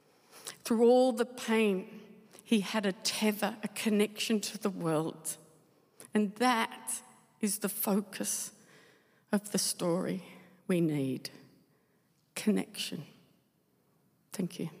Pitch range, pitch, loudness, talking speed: 175-215 Hz, 205 Hz, -32 LUFS, 105 wpm